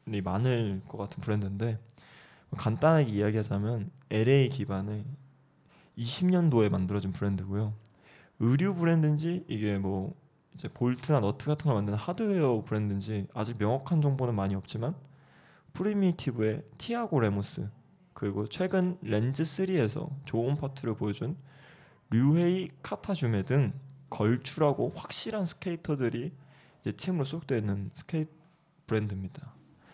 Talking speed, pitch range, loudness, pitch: 305 characters per minute, 105-155 Hz, -30 LUFS, 135 Hz